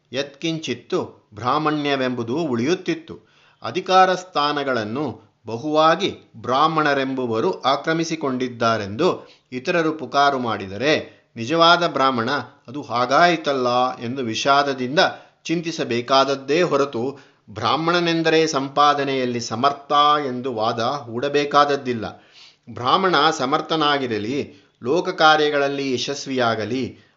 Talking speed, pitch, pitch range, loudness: 65 wpm, 140 Hz, 125-155 Hz, -20 LUFS